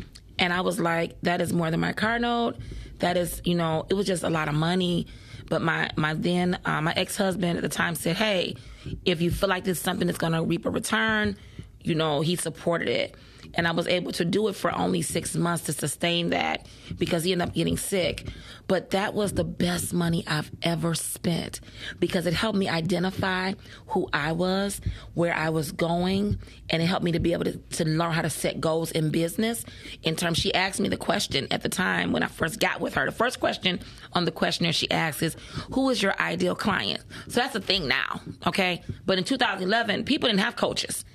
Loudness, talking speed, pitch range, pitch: -26 LUFS, 220 wpm, 165-190 Hz, 175 Hz